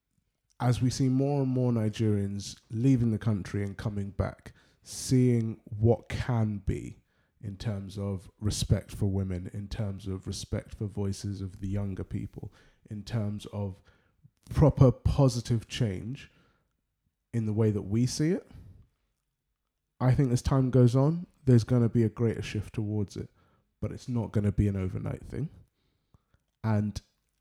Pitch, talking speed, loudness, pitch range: 110 Hz, 155 wpm, -29 LUFS, 100-120 Hz